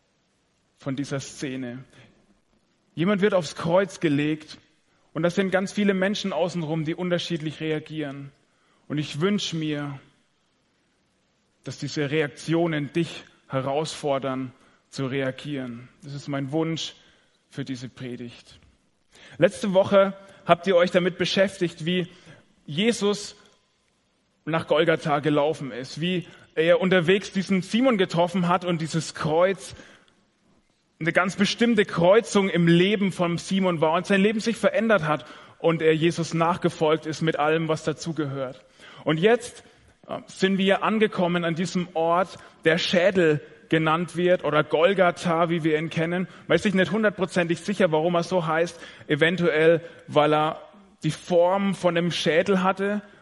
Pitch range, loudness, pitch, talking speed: 155-185 Hz, -24 LUFS, 170 Hz, 135 wpm